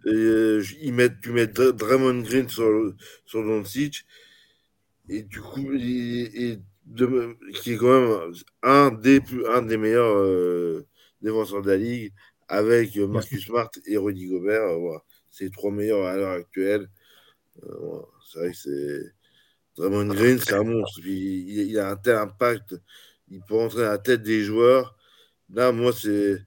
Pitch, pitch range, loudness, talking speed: 110 Hz, 100-120 Hz, -23 LUFS, 160 wpm